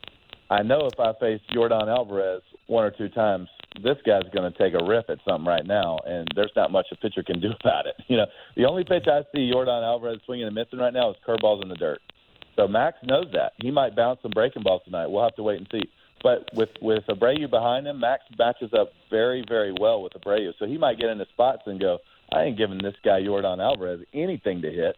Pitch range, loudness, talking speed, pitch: 105-135 Hz, -24 LUFS, 240 wpm, 115 Hz